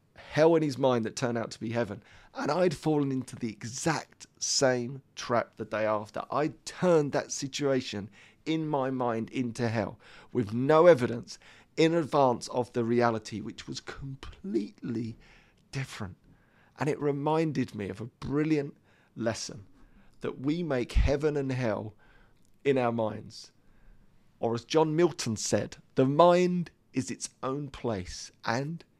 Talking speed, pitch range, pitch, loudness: 145 wpm, 110-145 Hz, 125 Hz, -29 LUFS